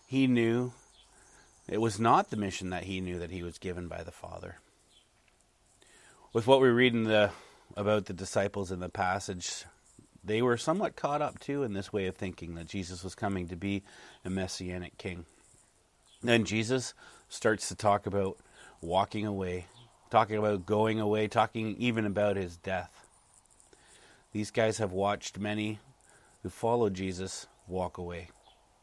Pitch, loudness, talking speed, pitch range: 100 Hz, -31 LUFS, 160 wpm, 95-110 Hz